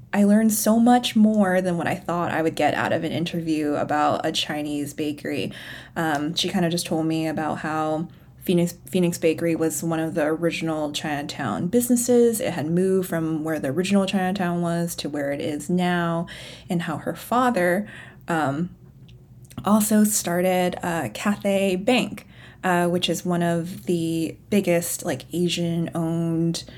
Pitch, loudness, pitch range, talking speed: 170 Hz, -23 LUFS, 160-185 Hz, 165 wpm